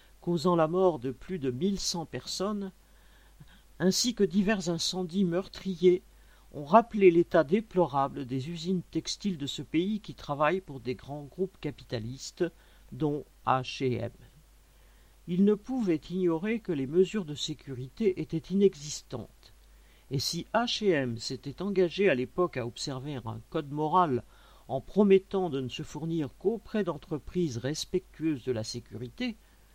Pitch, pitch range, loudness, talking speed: 165 Hz, 135-190 Hz, -30 LUFS, 135 wpm